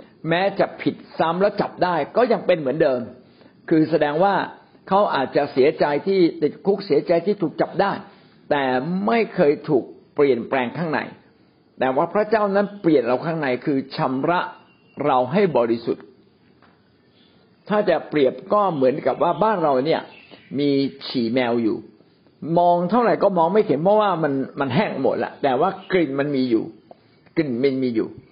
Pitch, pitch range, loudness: 165 Hz, 135-195 Hz, -21 LUFS